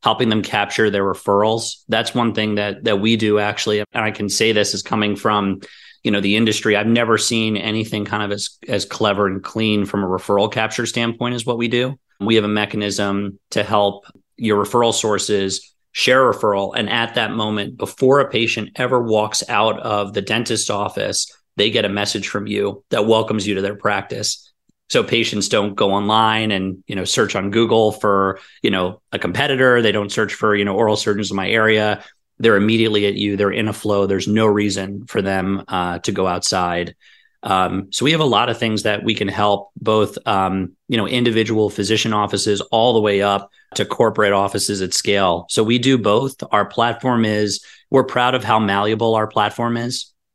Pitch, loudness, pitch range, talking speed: 105 Hz, -18 LUFS, 100-110 Hz, 200 wpm